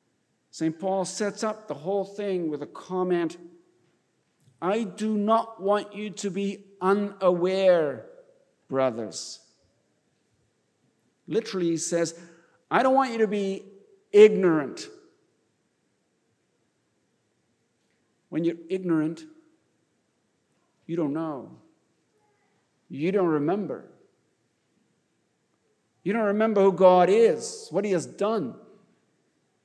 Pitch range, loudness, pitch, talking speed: 170-220 Hz, -25 LUFS, 195 Hz, 95 wpm